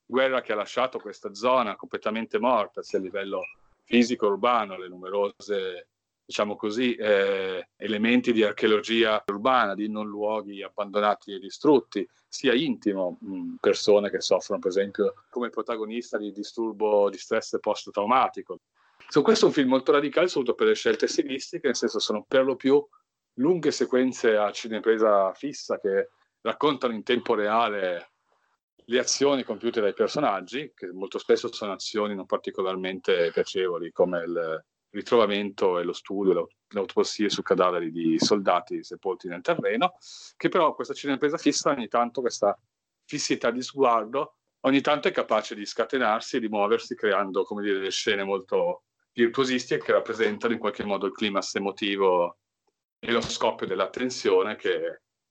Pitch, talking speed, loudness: 145 Hz, 150 wpm, -26 LUFS